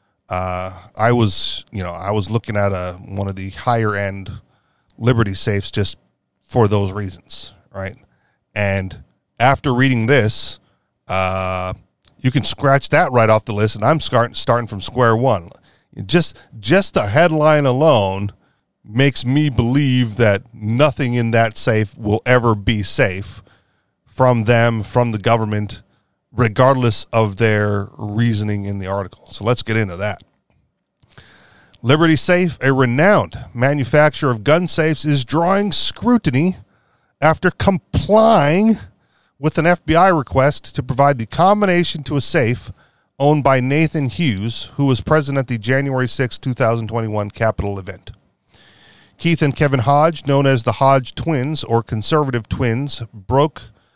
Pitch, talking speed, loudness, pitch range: 120 Hz, 145 wpm, -17 LUFS, 105-145 Hz